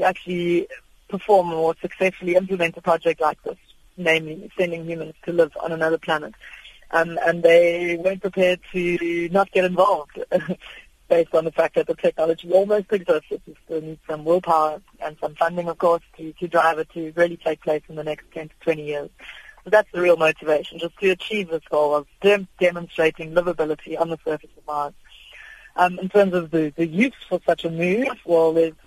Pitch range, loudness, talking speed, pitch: 160-185 Hz, -21 LUFS, 195 wpm, 170 Hz